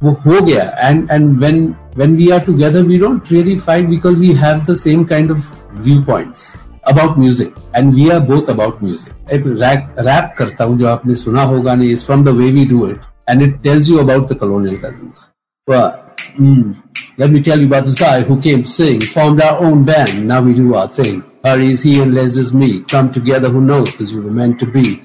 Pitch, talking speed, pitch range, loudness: 135 Hz, 205 wpm, 125-155 Hz, -11 LUFS